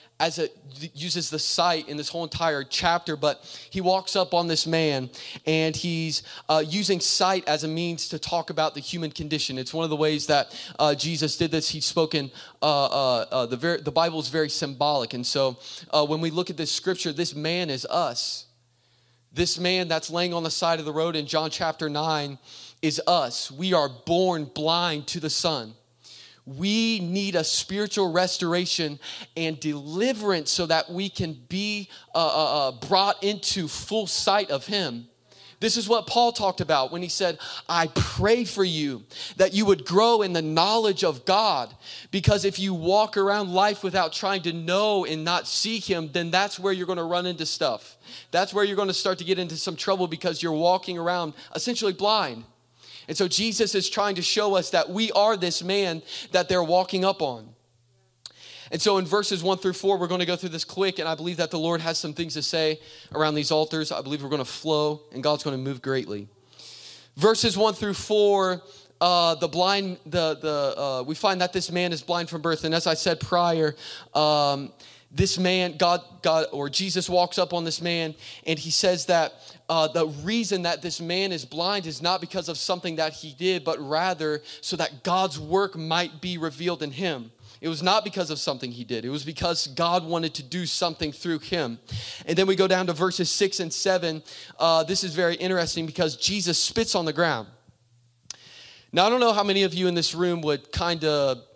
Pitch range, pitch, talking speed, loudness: 150-185 Hz, 170 Hz, 205 wpm, -24 LUFS